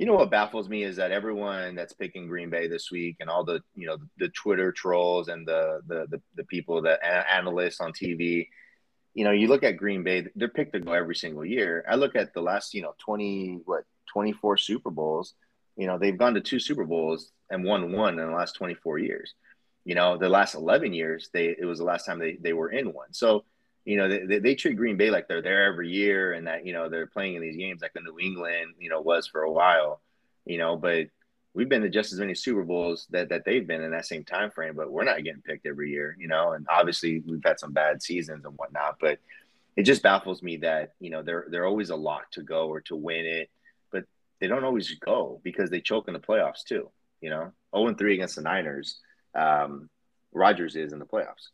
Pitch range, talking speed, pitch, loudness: 80-95 Hz, 240 wpm, 85 Hz, -27 LUFS